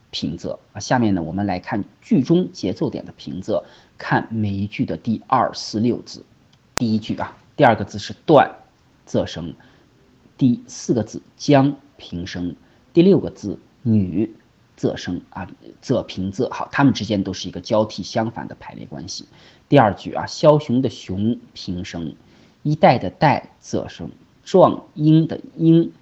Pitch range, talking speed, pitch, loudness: 95-135 Hz, 220 characters per minute, 110 Hz, -20 LUFS